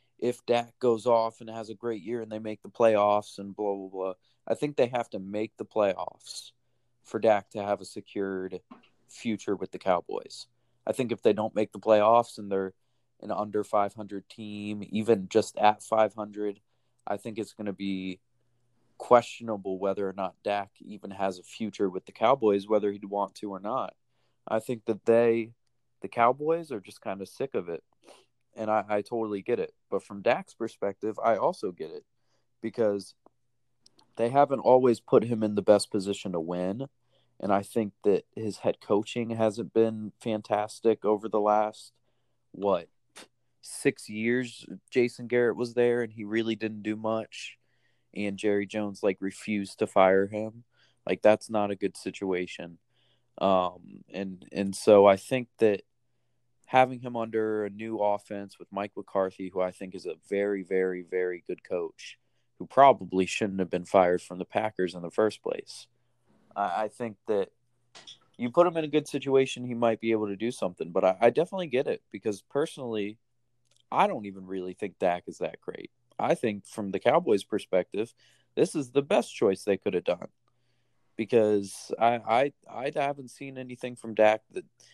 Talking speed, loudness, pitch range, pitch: 180 wpm, -28 LUFS, 100-120 Hz, 110 Hz